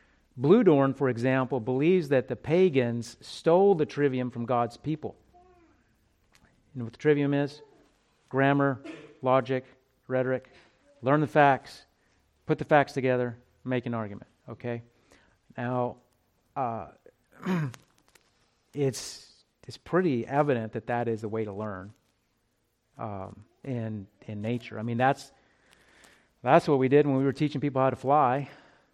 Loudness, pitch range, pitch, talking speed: -27 LUFS, 120-140 Hz, 130 Hz, 135 wpm